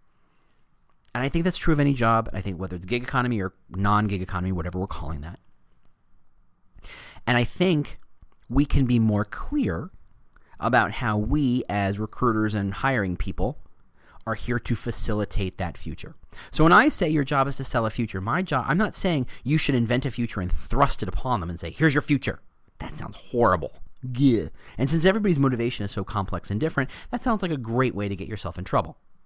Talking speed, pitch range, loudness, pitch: 205 wpm, 100-140 Hz, -25 LUFS, 120 Hz